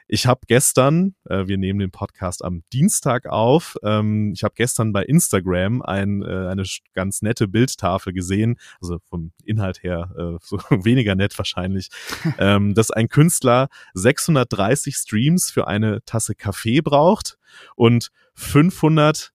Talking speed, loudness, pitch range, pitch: 145 wpm, -19 LUFS, 95-130 Hz, 110 Hz